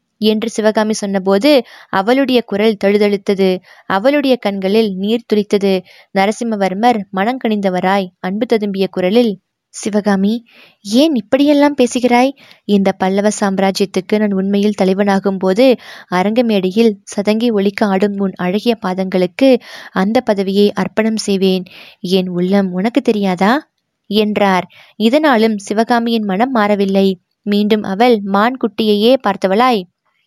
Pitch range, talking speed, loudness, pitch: 195-230 Hz, 105 wpm, -14 LUFS, 205 Hz